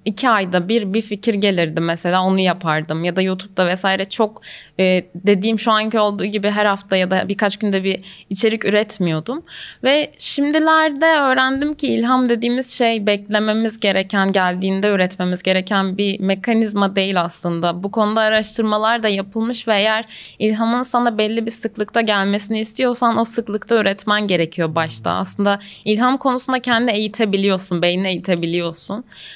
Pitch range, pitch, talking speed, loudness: 190-225 Hz, 210 Hz, 145 wpm, -18 LUFS